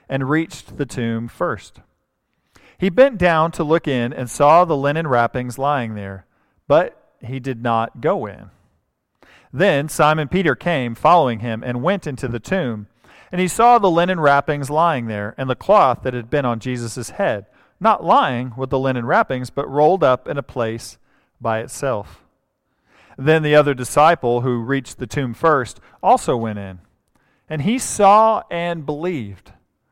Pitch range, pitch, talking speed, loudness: 120-155 Hz, 130 Hz, 165 wpm, -18 LUFS